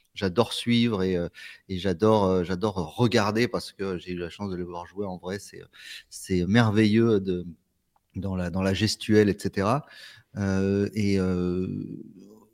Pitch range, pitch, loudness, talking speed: 90-110 Hz, 95 Hz, -26 LUFS, 155 wpm